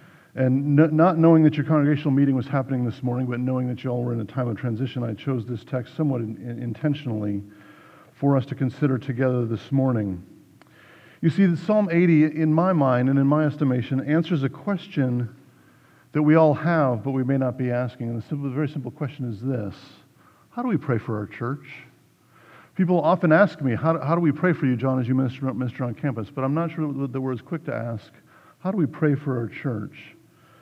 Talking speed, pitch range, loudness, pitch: 225 wpm, 125-155 Hz, -23 LUFS, 135 Hz